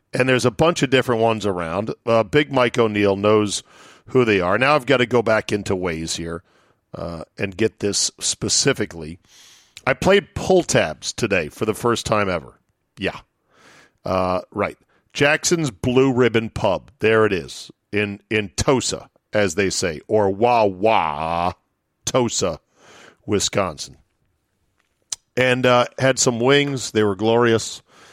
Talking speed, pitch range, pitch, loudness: 145 wpm, 100-125 Hz, 110 Hz, -19 LUFS